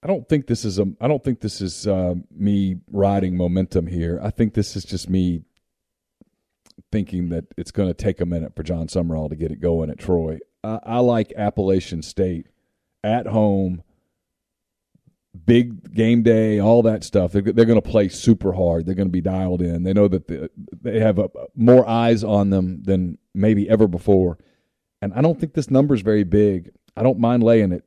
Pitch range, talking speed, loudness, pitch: 90-115 Hz, 200 wpm, -20 LUFS, 100 Hz